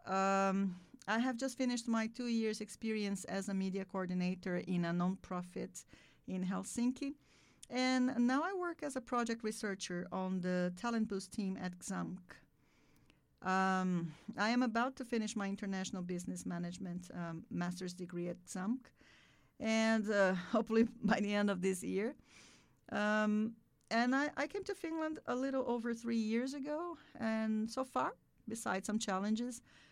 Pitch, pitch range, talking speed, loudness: 215 Hz, 185-240 Hz, 150 wpm, -38 LUFS